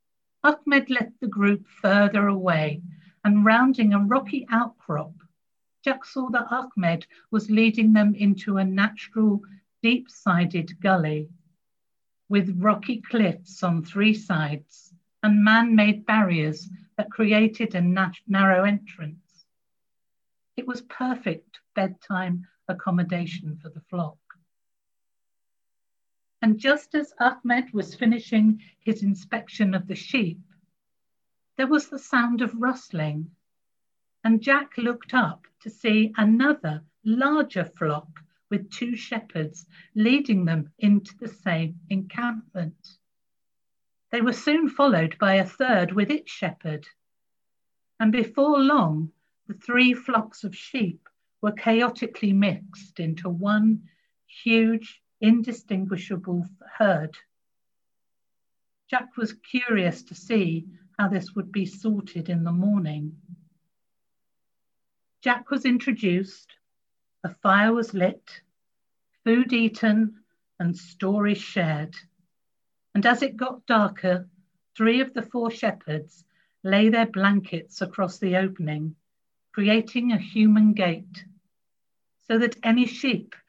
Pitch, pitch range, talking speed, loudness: 205 Hz, 180-230 Hz, 115 wpm, -23 LUFS